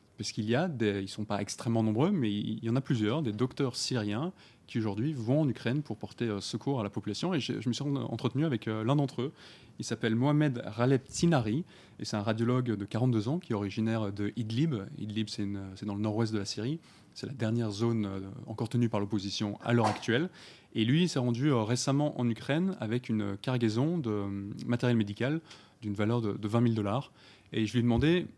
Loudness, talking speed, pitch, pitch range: -31 LUFS, 220 wpm, 115 Hz, 105-135 Hz